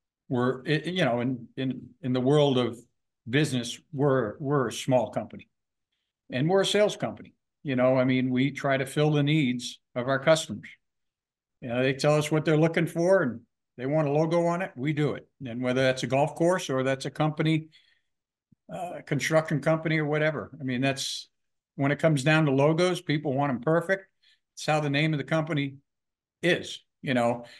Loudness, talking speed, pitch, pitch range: -26 LUFS, 195 wpm, 145 Hz, 130-155 Hz